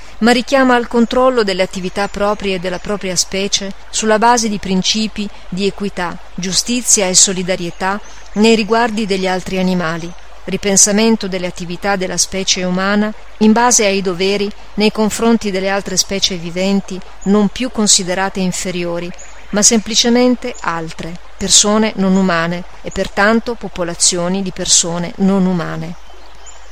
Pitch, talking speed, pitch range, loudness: 195 Hz, 130 wpm, 185-215 Hz, -14 LUFS